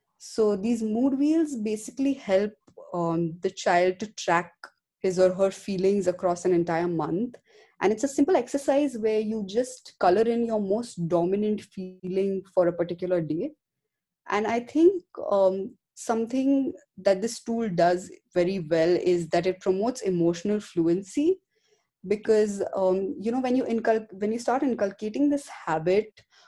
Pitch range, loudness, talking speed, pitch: 185-245 Hz, -26 LUFS, 150 wpm, 210 Hz